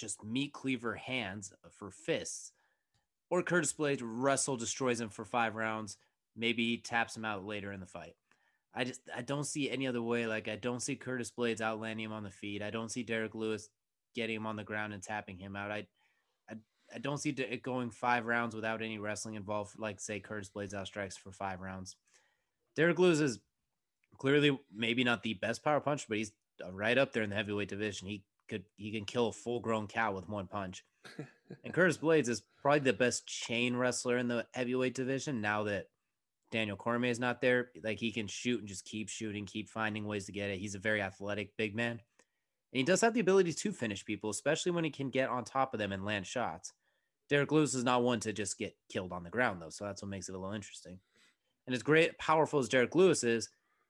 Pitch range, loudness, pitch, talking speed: 105-125 Hz, -35 LUFS, 115 Hz, 220 wpm